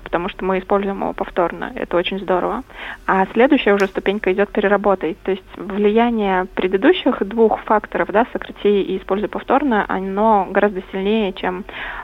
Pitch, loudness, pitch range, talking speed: 200 Hz, -18 LUFS, 190-215 Hz, 150 wpm